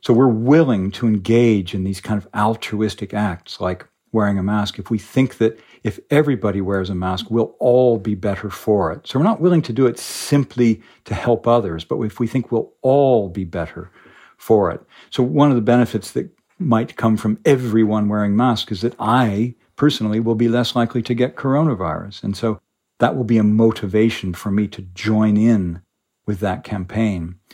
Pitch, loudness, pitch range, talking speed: 110 Hz, -19 LUFS, 100-120 Hz, 195 wpm